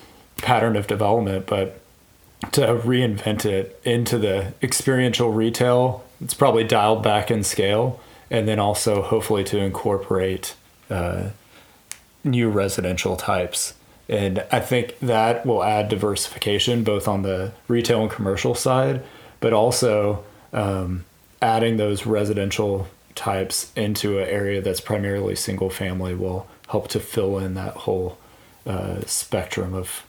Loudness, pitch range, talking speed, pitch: -22 LUFS, 95-115 Hz, 130 wpm, 105 Hz